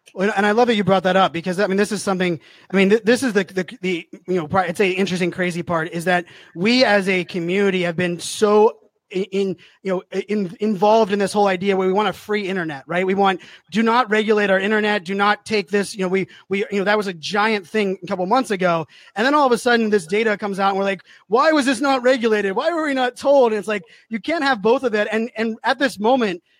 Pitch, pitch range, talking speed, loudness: 205 Hz, 185-220 Hz, 260 wpm, -19 LUFS